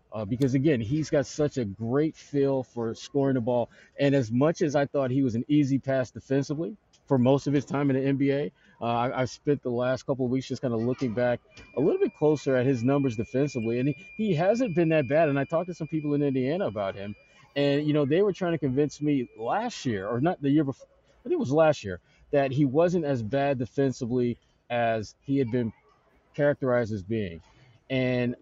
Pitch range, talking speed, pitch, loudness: 125-150 Hz, 230 wpm, 135 Hz, -27 LUFS